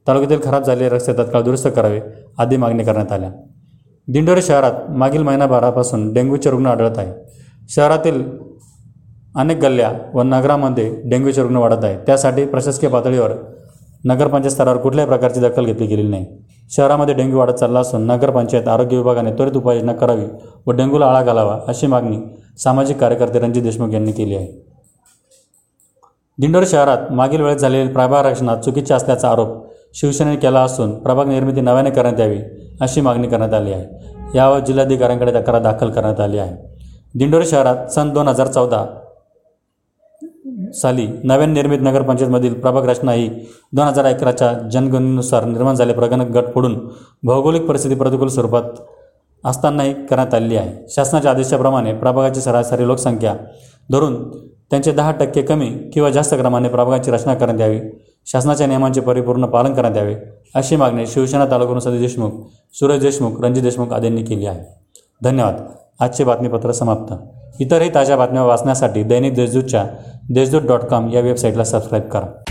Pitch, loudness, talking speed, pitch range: 125 Hz, -15 LUFS, 145 wpm, 115-135 Hz